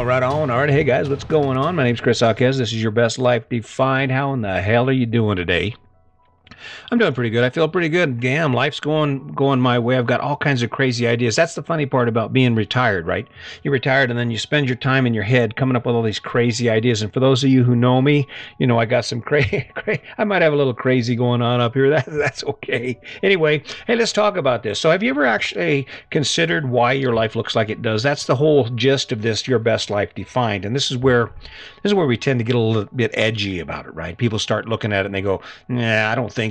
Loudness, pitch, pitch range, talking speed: -19 LUFS, 125 Hz, 115-140 Hz, 265 wpm